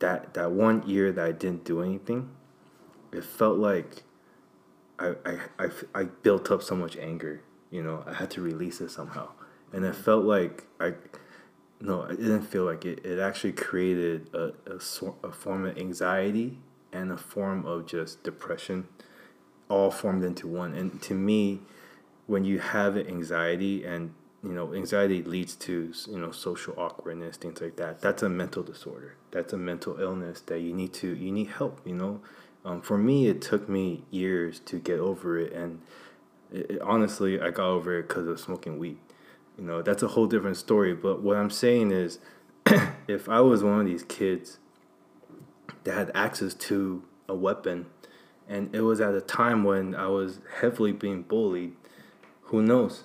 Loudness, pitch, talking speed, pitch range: -29 LUFS, 95 Hz, 180 wpm, 85-100 Hz